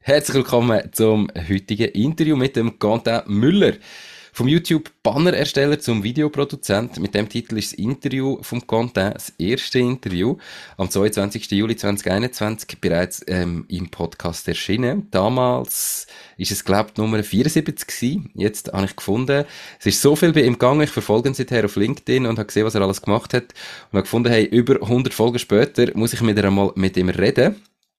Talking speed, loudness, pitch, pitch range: 175 wpm, -20 LUFS, 115 Hz, 100-130 Hz